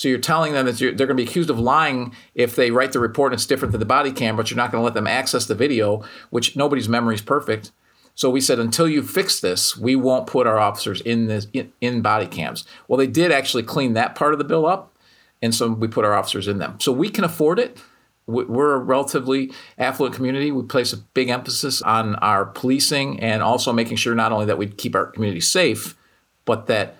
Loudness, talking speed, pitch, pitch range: -20 LUFS, 240 wpm, 125 Hz, 115-135 Hz